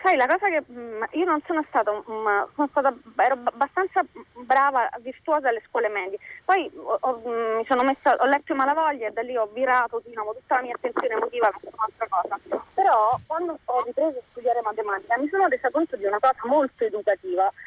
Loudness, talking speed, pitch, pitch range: -24 LUFS, 195 wpm, 260 Hz, 230-315 Hz